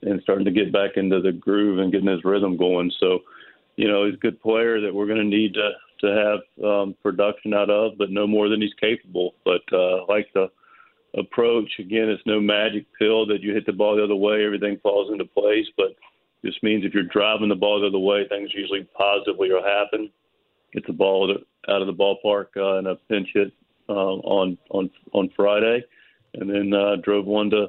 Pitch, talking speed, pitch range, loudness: 105 Hz, 215 wpm, 100-110 Hz, -22 LUFS